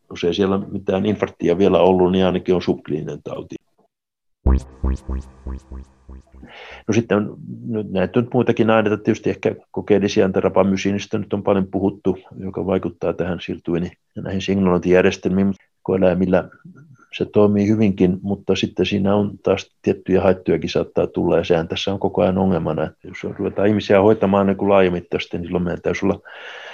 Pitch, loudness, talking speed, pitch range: 95 Hz, -19 LUFS, 145 wpm, 90-100 Hz